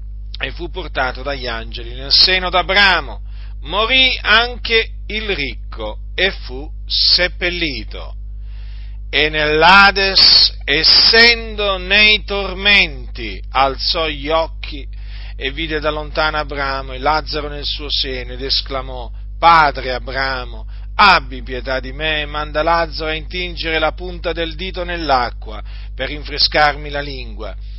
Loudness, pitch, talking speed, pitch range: -14 LUFS, 145 Hz, 120 wpm, 115-170 Hz